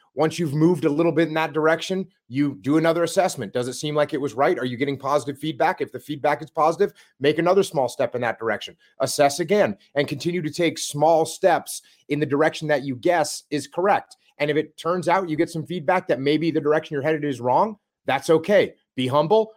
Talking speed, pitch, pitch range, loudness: 225 wpm, 155 Hz, 145-170 Hz, -22 LUFS